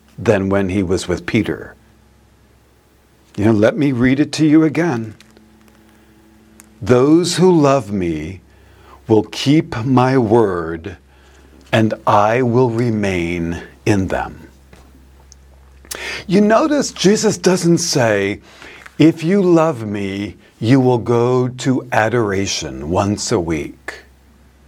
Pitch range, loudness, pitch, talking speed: 85-130 Hz, -16 LUFS, 110 Hz, 110 wpm